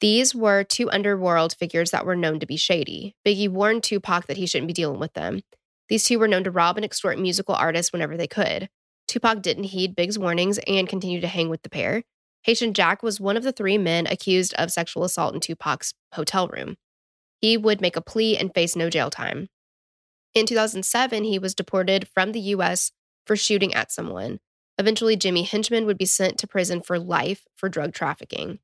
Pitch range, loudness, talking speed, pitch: 175-215 Hz, -23 LUFS, 205 wpm, 190 Hz